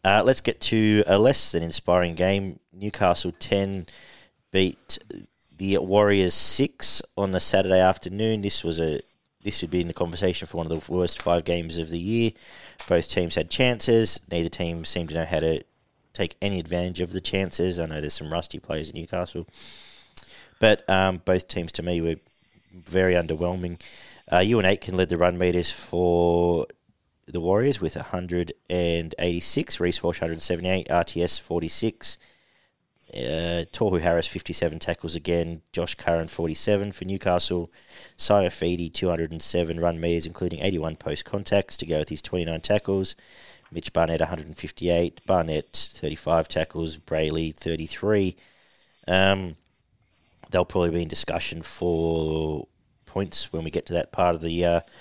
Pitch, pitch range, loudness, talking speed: 85 Hz, 85-95 Hz, -25 LUFS, 155 wpm